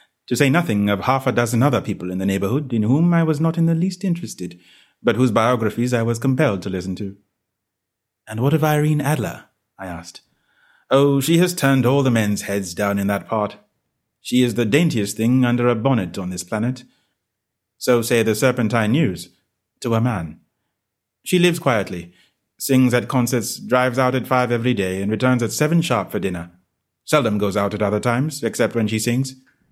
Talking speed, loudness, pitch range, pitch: 195 wpm, -19 LUFS, 100-130 Hz, 120 Hz